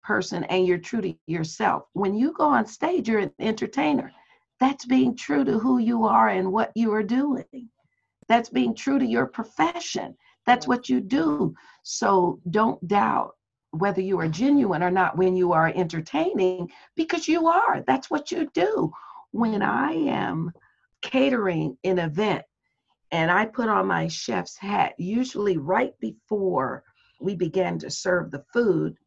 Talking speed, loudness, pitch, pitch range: 160 wpm, -24 LUFS, 210 Hz, 180-255 Hz